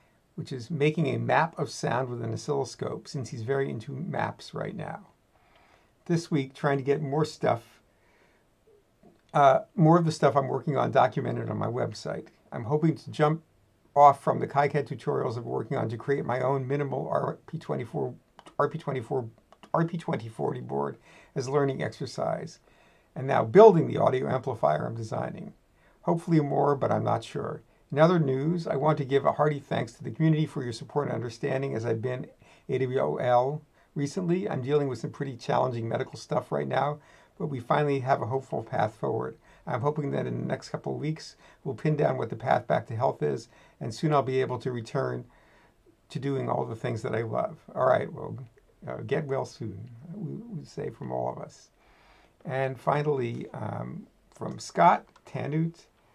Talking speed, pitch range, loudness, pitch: 180 wpm, 130-155 Hz, -28 LUFS, 140 Hz